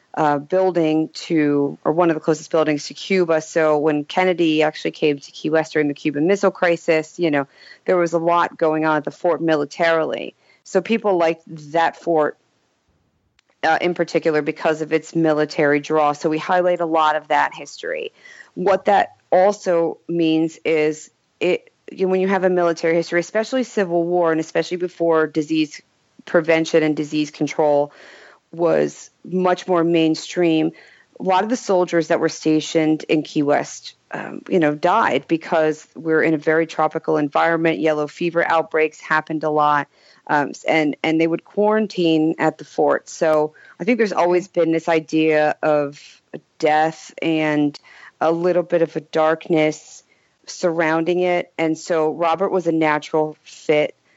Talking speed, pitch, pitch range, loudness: 165 wpm, 160 Hz, 155-170 Hz, -19 LUFS